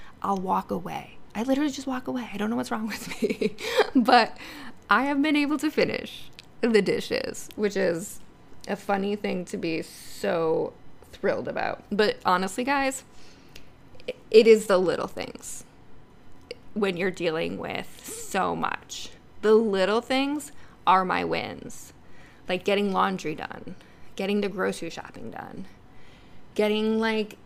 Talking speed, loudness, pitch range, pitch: 140 wpm, -26 LUFS, 195-265 Hz, 215 Hz